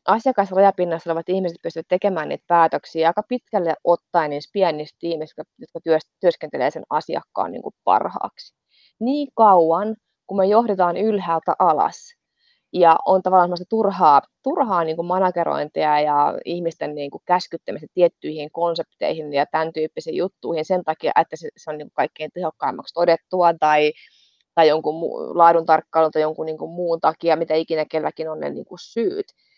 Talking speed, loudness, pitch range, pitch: 130 wpm, -20 LUFS, 160-190 Hz, 170 Hz